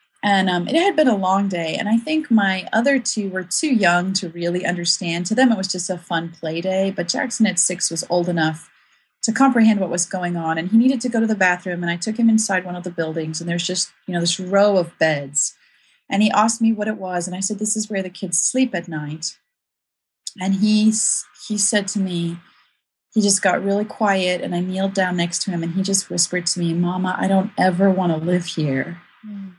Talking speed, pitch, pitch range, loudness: 240 wpm, 185 Hz, 175-215 Hz, -20 LUFS